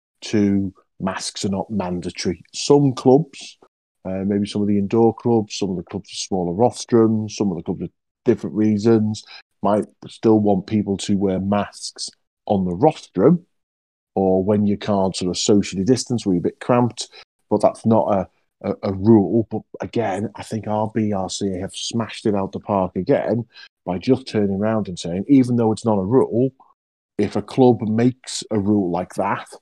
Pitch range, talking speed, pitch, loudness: 95-115 Hz, 185 wpm, 105 Hz, -20 LUFS